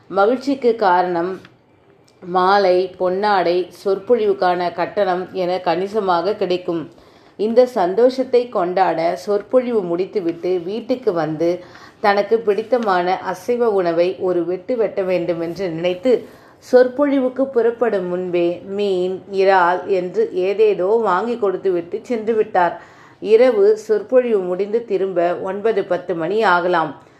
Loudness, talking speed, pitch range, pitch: -18 LUFS, 100 wpm, 180-235 Hz, 195 Hz